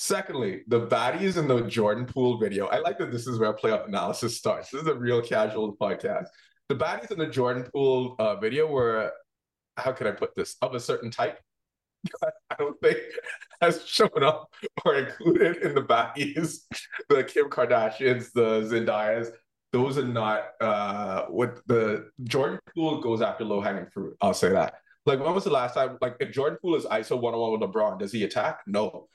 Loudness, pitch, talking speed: -27 LUFS, 130 Hz, 190 wpm